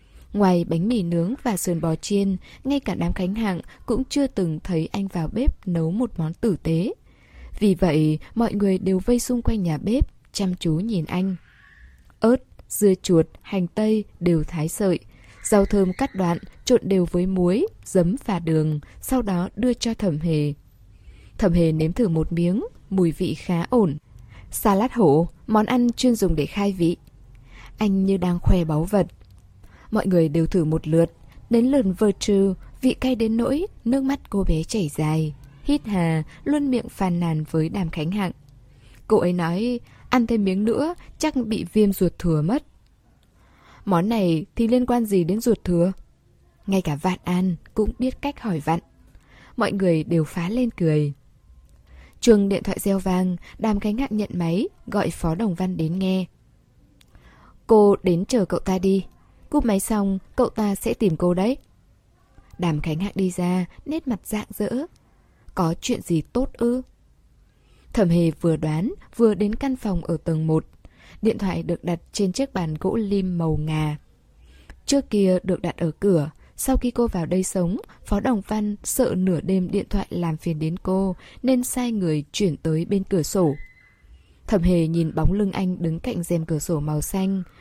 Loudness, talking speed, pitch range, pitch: -23 LUFS, 185 wpm, 165-215 Hz, 185 Hz